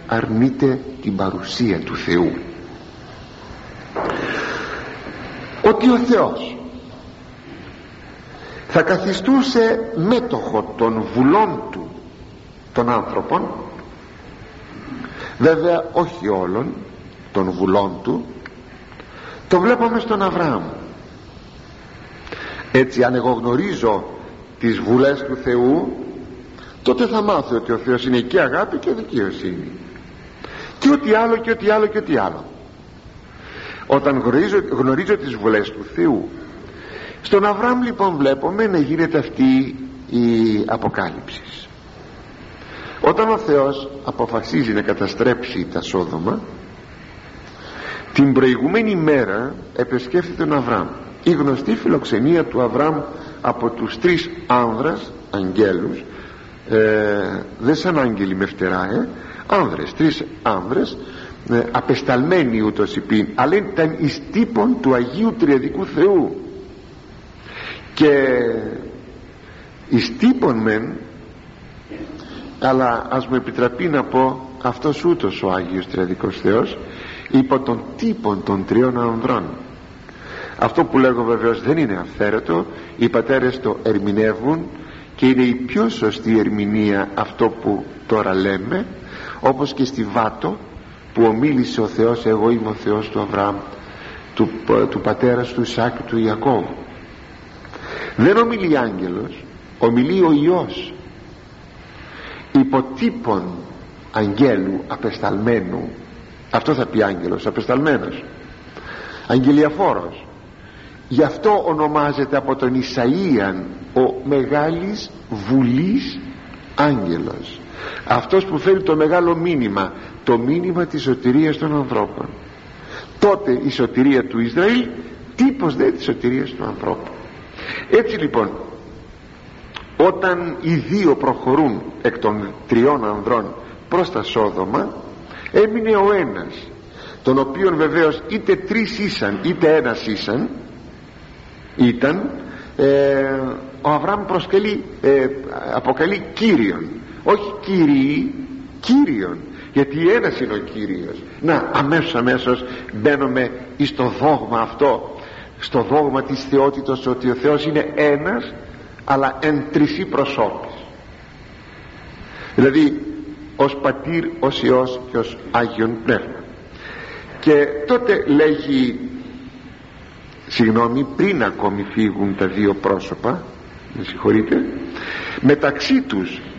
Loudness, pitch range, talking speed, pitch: -18 LUFS, 115-175 Hz, 105 wpm, 135 Hz